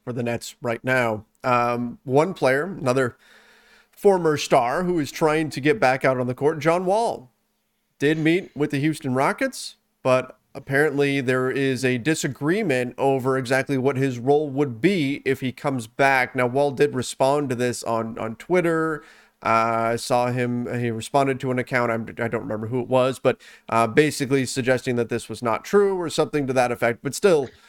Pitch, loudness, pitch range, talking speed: 135 Hz, -22 LUFS, 125-150 Hz, 190 wpm